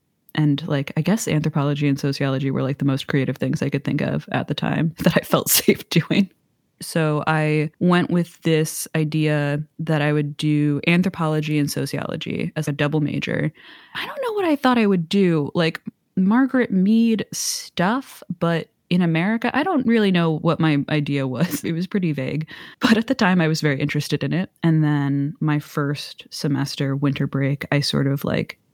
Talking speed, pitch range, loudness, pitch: 190 wpm, 145-180 Hz, -21 LUFS, 155 Hz